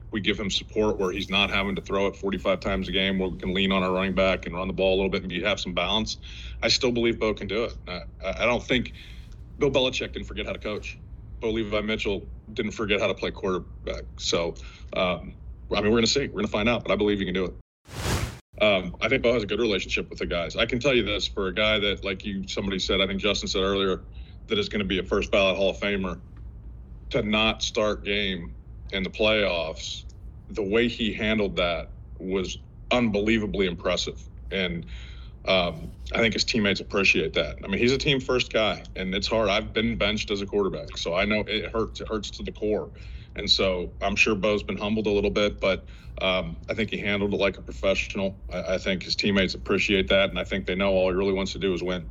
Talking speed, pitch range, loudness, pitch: 240 wpm, 95-105 Hz, -25 LUFS, 100 Hz